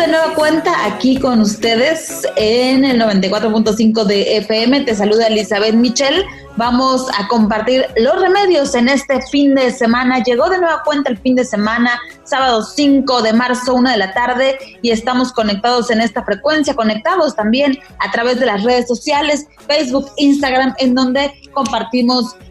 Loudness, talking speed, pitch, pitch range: -14 LUFS, 160 wpm, 250 Hz, 230-275 Hz